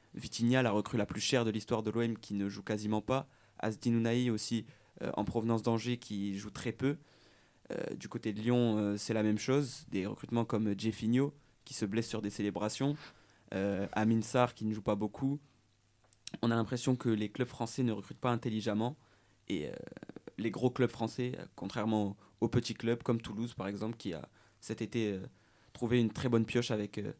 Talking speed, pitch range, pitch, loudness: 200 wpm, 105-120 Hz, 115 Hz, -35 LUFS